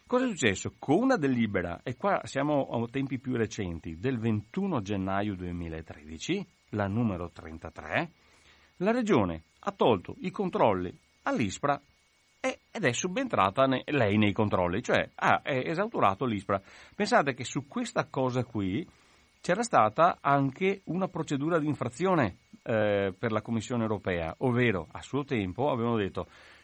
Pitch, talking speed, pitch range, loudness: 115 Hz, 140 wpm, 100-150 Hz, -29 LUFS